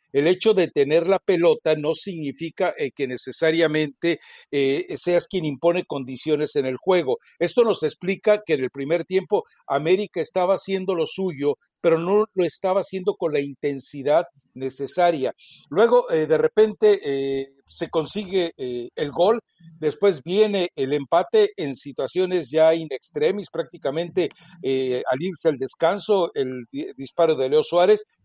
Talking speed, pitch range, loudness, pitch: 150 wpm, 145-190 Hz, -22 LUFS, 165 Hz